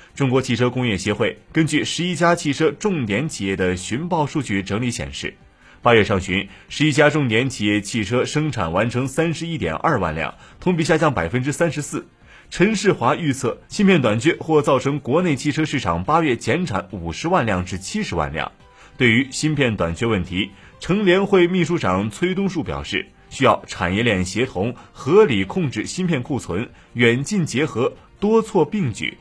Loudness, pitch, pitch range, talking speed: -20 LUFS, 140 Hz, 110-165 Hz, 275 characters per minute